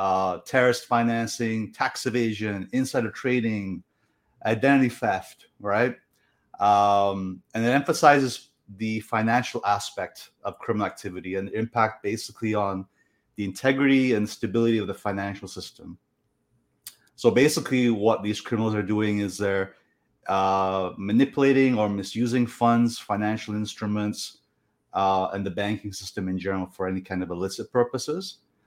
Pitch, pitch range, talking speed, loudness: 105 Hz, 95-120 Hz, 130 wpm, -25 LUFS